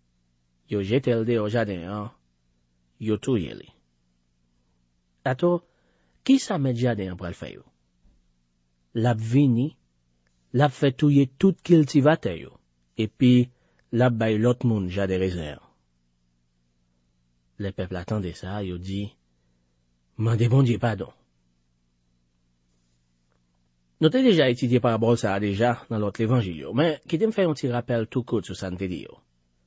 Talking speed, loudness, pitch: 140 wpm, -24 LUFS, 95 Hz